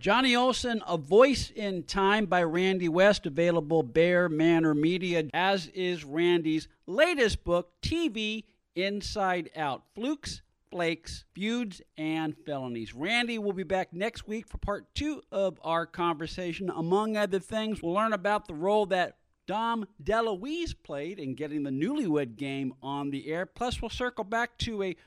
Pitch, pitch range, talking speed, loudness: 185 Hz, 165-220 Hz, 155 wpm, -29 LUFS